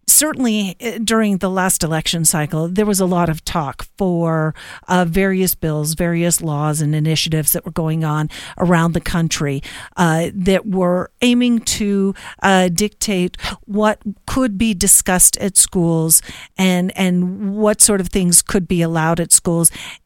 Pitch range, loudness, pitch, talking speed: 165-200 Hz, -15 LUFS, 180 Hz, 155 wpm